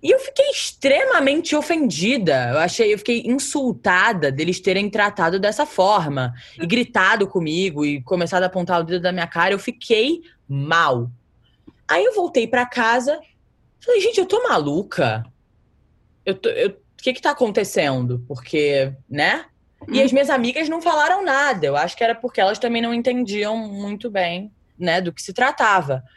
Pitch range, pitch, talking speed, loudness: 170-275 Hz, 210 Hz, 165 wpm, -19 LUFS